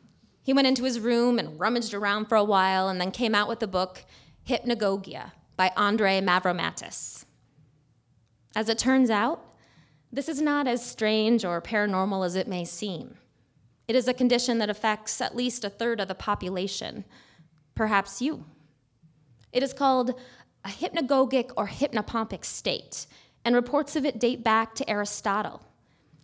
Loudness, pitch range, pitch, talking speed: -26 LUFS, 185-245 Hz, 215 Hz, 155 wpm